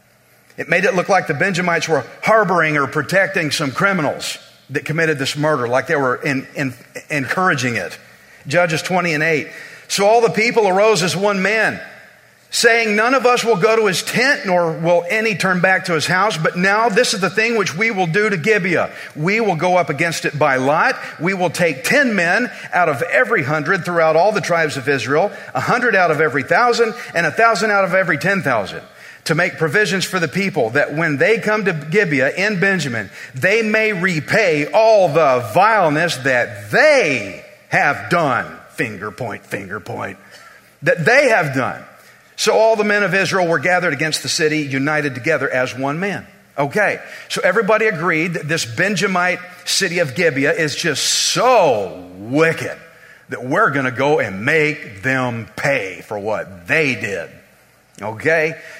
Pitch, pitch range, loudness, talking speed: 175 Hz, 155-205 Hz, -16 LUFS, 180 wpm